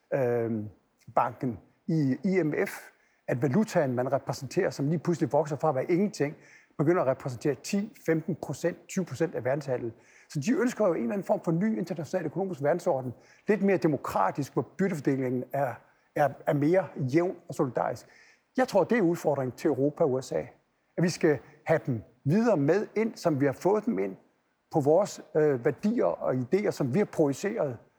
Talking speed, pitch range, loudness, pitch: 170 wpm, 135-185 Hz, -28 LUFS, 155 Hz